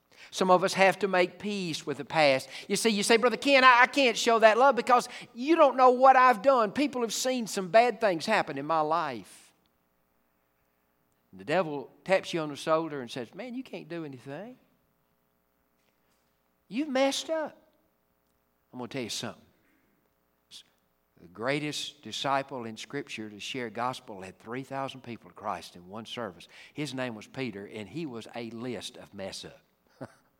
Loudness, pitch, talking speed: -26 LUFS, 145 Hz, 180 wpm